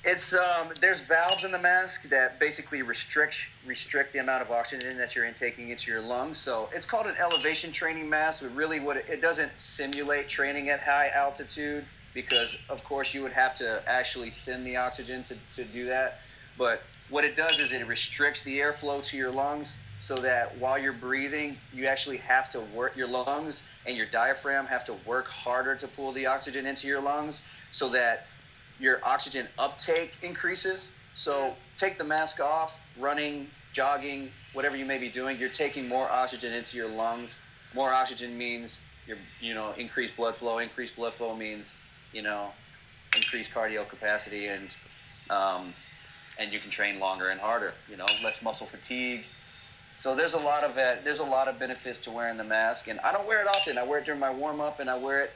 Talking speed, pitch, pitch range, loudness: 195 wpm, 135 Hz, 120-145 Hz, -28 LUFS